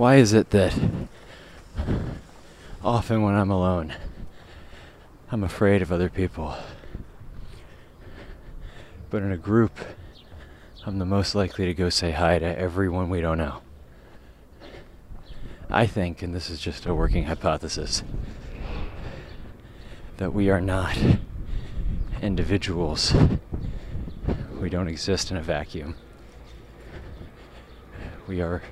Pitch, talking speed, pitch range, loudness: 90 Hz, 110 wpm, 80-100 Hz, -25 LUFS